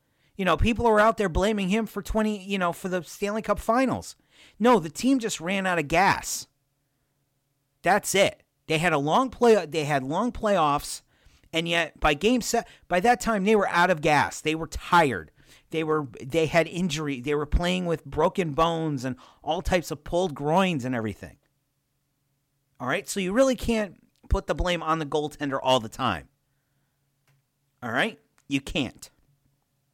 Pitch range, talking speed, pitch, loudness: 140-195 Hz, 180 wpm, 160 Hz, -25 LUFS